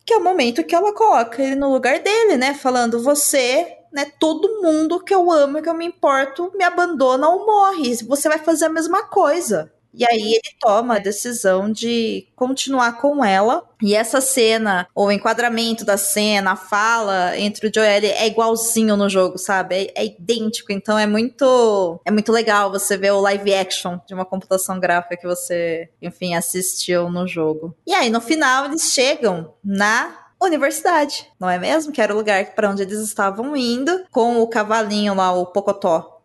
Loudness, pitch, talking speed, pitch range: -18 LUFS, 225 Hz, 185 wpm, 195-285 Hz